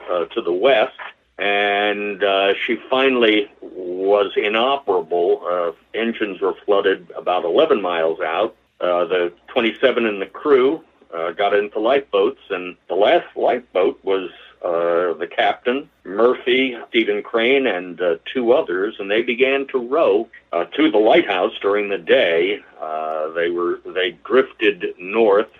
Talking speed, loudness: 145 wpm, -19 LUFS